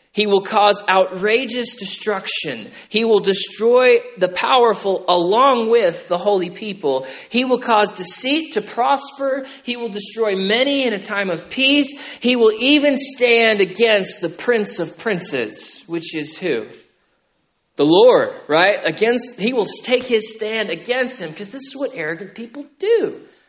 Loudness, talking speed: -17 LUFS, 155 wpm